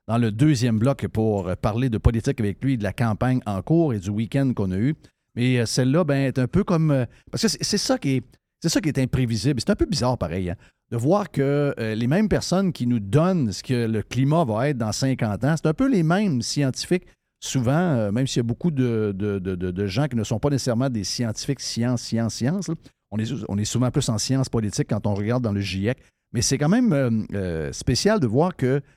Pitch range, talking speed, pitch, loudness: 110-145 Hz, 250 wpm, 125 Hz, -23 LUFS